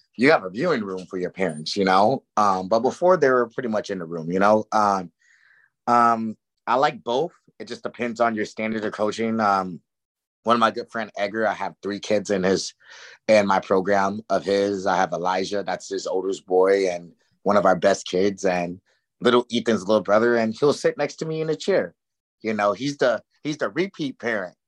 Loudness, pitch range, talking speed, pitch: -22 LUFS, 95-115 Hz, 215 wpm, 105 Hz